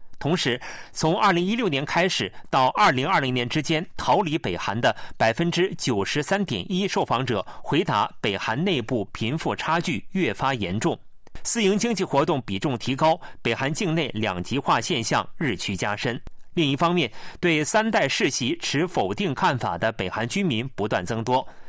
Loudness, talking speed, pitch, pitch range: -24 LUFS, 260 characters per minute, 155 Hz, 115-180 Hz